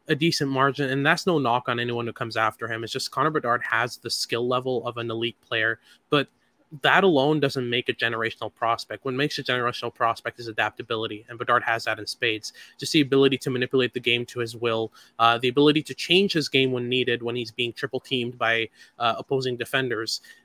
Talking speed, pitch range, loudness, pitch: 215 wpm, 115-135 Hz, -24 LUFS, 120 Hz